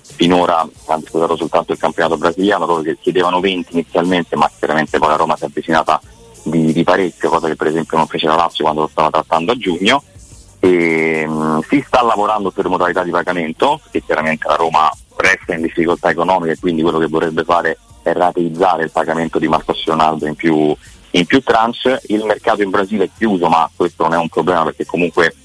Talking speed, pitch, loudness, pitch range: 200 wpm, 85 Hz, -15 LUFS, 80-90 Hz